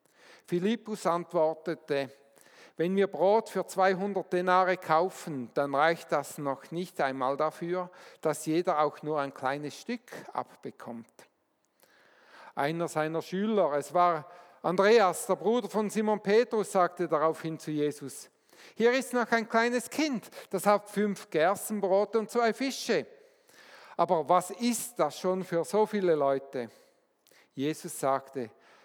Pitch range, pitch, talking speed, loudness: 150-210 Hz, 175 Hz, 130 wpm, -29 LUFS